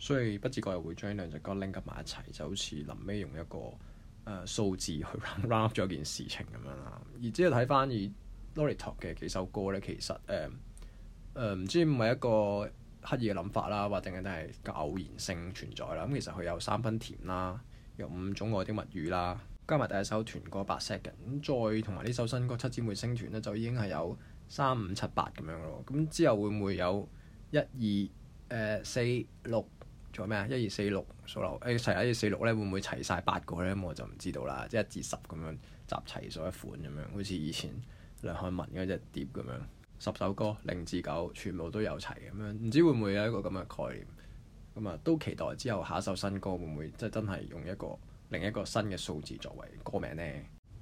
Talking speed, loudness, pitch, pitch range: 320 characters per minute, -35 LUFS, 105 Hz, 90-115 Hz